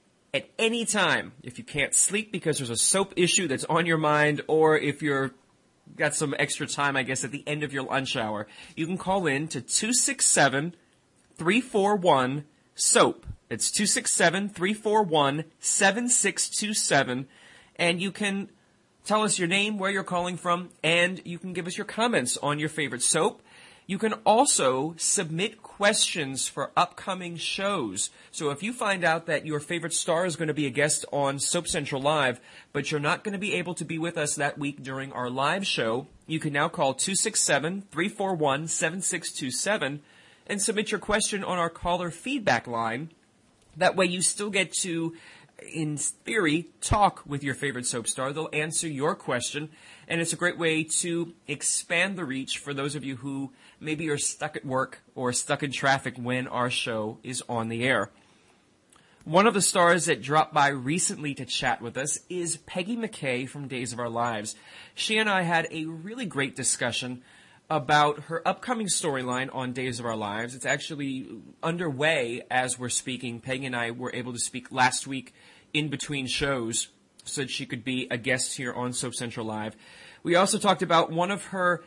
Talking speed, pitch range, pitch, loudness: 180 wpm, 135-180 Hz, 155 Hz, -26 LUFS